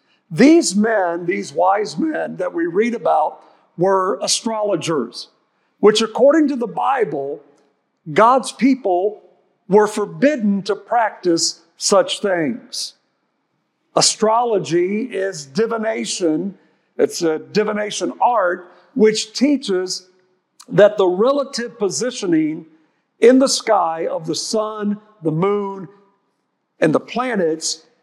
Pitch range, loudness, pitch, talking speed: 185-235 Hz, -18 LUFS, 205 Hz, 105 wpm